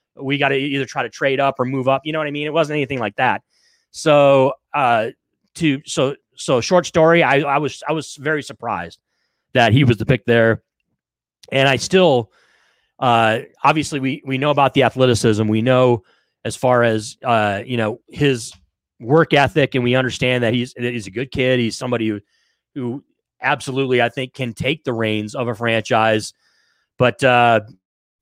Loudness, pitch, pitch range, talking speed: -18 LUFS, 130 Hz, 115-140 Hz, 190 wpm